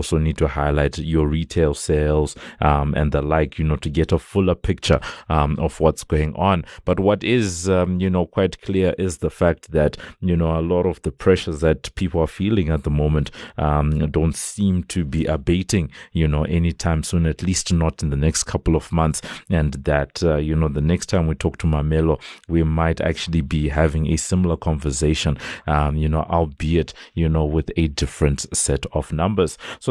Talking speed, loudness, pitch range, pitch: 205 wpm, -21 LUFS, 75-90 Hz, 80 Hz